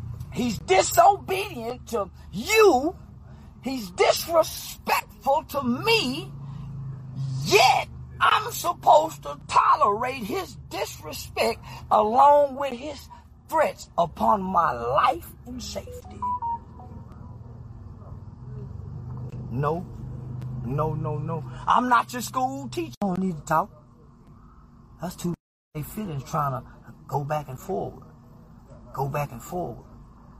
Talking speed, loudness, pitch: 105 wpm, -24 LUFS, 150 Hz